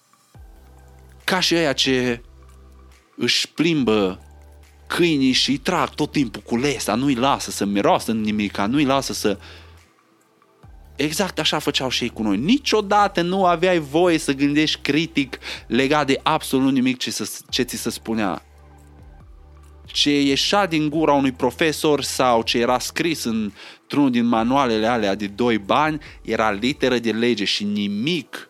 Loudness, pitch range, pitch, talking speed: -20 LUFS, 100-155 Hz, 125 Hz, 150 wpm